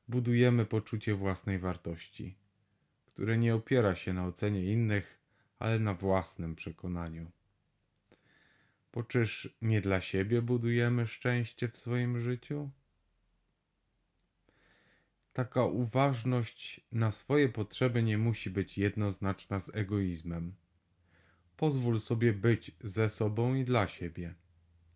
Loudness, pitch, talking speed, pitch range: -33 LUFS, 110 Hz, 105 wpm, 95-120 Hz